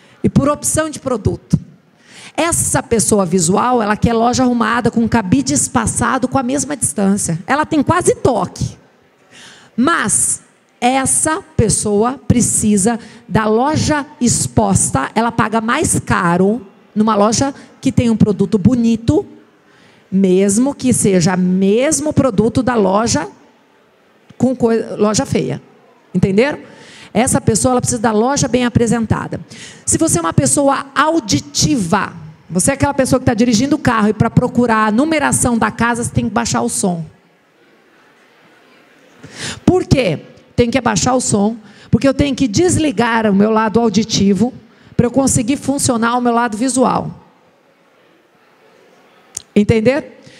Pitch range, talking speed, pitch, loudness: 210-260 Hz, 135 wpm, 235 Hz, -14 LUFS